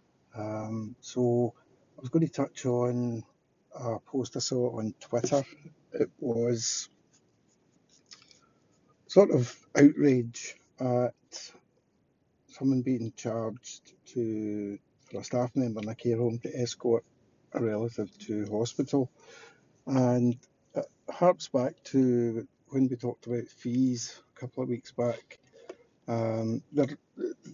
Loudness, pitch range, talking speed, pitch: -30 LUFS, 115-135 Hz, 120 wpm, 125 Hz